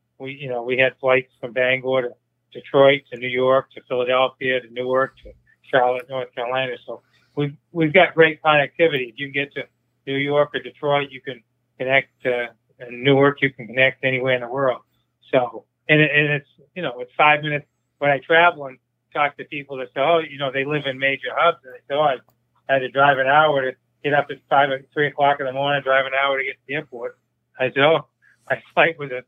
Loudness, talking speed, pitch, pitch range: -20 LUFS, 225 wpm, 135 Hz, 125-145 Hz